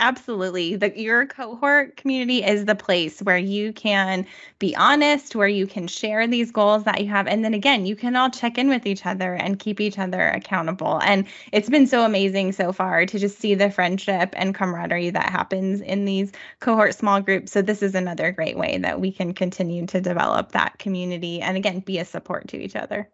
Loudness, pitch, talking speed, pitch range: -21 LUFS, 200 Hz, 210 wpm, 185-220 Hz